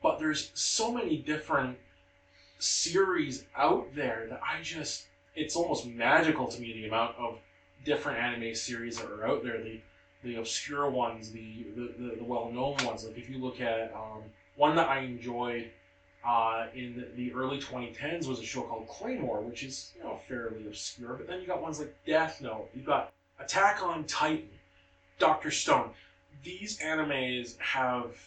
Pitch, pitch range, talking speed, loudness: 120 Hz, 110-140 Hz, 170 wpm, -32 LUFS